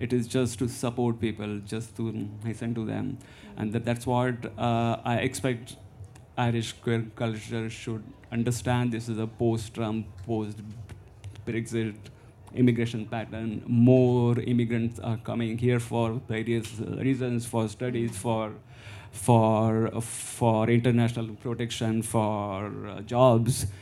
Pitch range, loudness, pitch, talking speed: 110-120 Hz, -28 LUFS, 115 Hz, 125 wpm